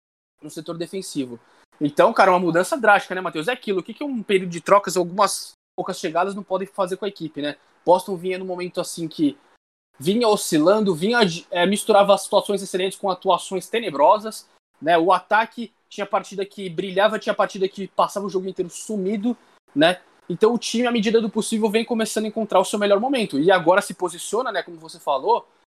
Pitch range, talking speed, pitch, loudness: 180-215 Hz, 195 wpm, 195 Hz, -21 LUFS